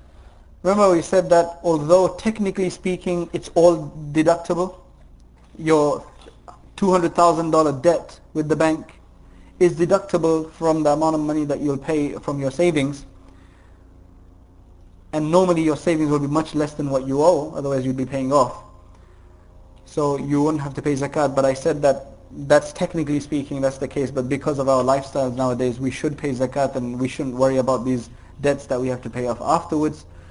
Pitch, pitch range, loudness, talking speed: 145 Hz, 125-160 Hz, -21 LUFS, 170 wpm